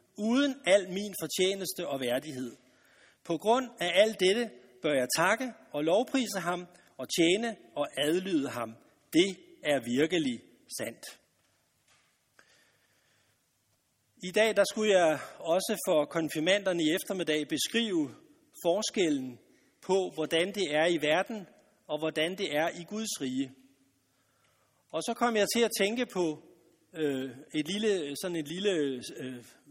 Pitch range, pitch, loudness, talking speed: 155-215 Hz, 180 Hz, -30 LUFS, 135 wpm